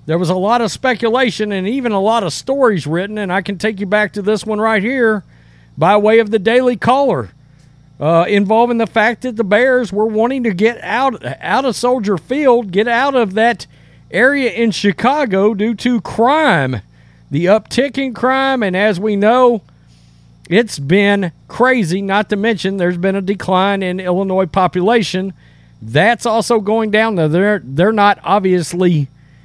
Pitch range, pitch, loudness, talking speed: 180-235 Hz, 210 Hz, -14 LUFS, 175 wpm